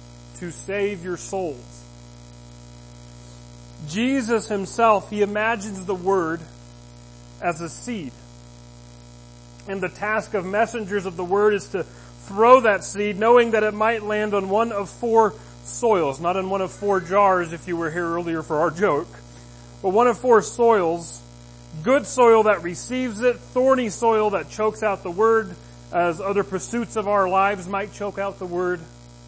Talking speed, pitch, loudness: 160 wpm, 190 Hz, -21 LUFS